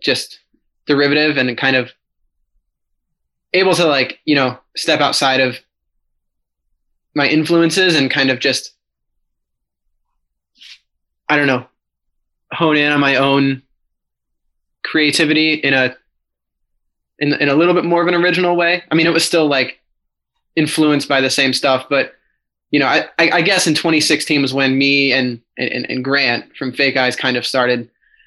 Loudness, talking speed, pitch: -15 LUFS, 155 wpm, 135 Hz